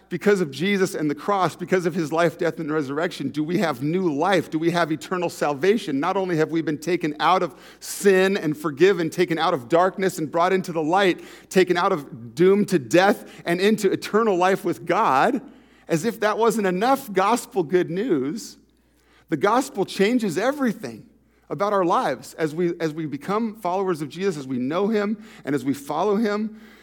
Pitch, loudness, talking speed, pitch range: 185 Hz, -22 LUFS, 195 wpm, 165-200 Hz